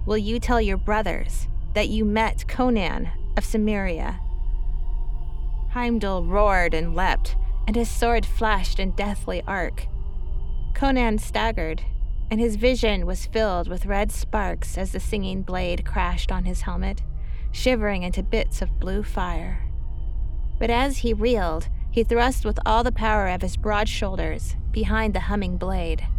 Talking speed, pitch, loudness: 145 wpm, 200 Hz, -25 LUFS